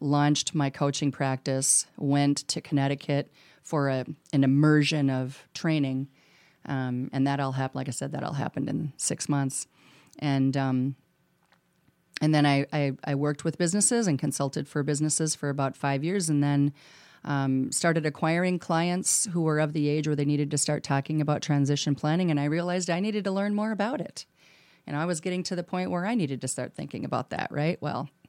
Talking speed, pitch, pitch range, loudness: 195 wpm, 145 Hz, 140-160 Hz, -27 LUFS